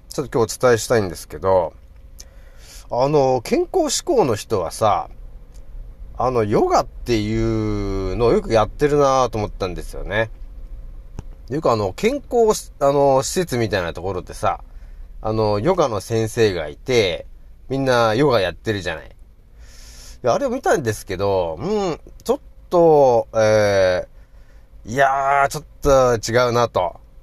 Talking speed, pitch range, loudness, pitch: 285 characters per minute, 95-140 Hz, -19 LUFS, 115 Hz